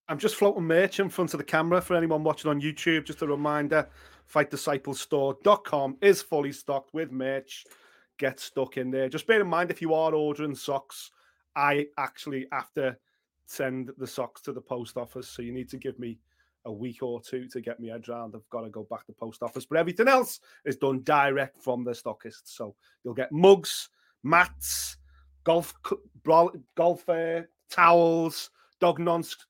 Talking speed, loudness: 180 wpm, -27 LUFS